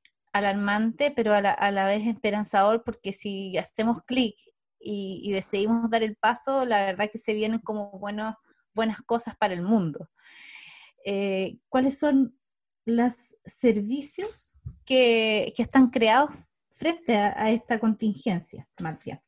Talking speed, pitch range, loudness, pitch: 140 wpm, 205-240 Hz, -26 LUFS, 220 Hz